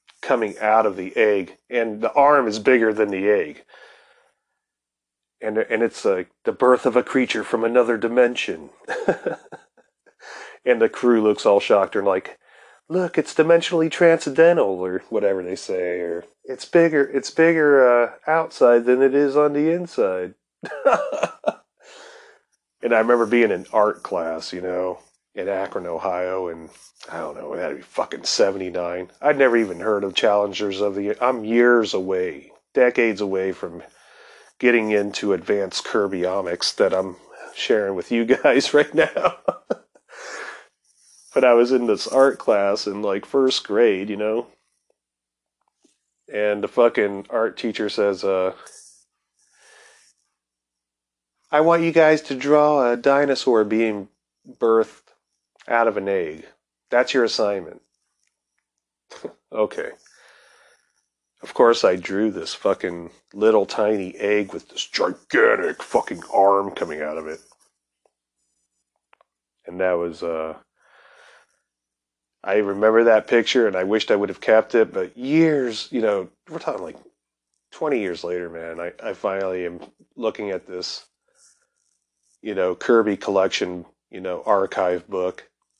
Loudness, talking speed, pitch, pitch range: -20 LUFS, 140 wpm, 105 Hz, 90-130 Hz